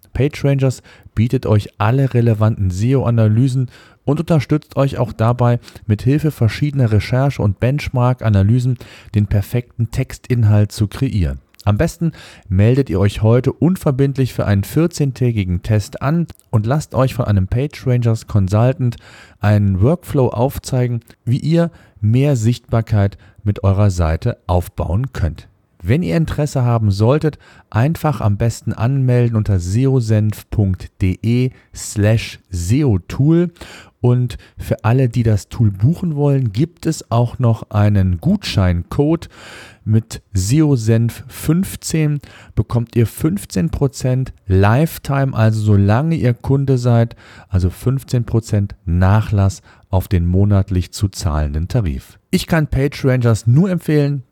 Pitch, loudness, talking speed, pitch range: 115 Hz, -17 LUFS, 115 wpm, 105-135 Hz